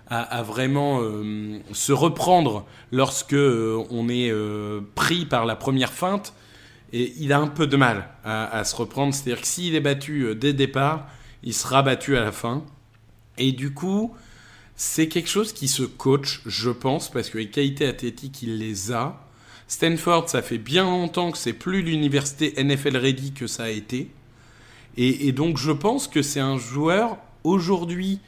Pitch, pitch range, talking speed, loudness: 135 Hz, 115-150 Hz, 180 wpm, -23 LUFS